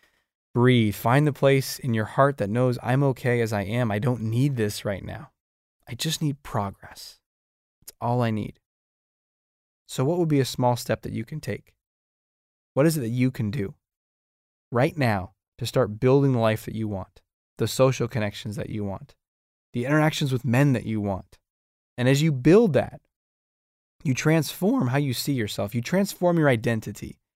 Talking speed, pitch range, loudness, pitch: 185 wpm, 105-135 Hz, -24 LUFS, 120 Hz